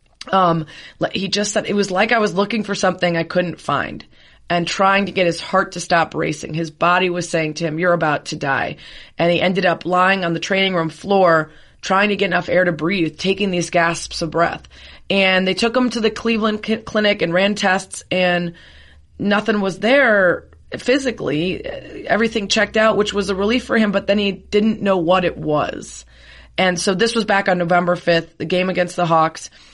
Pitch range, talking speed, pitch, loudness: 170-205 Hz, 210 wpm, 185 Hz, -18 LUFS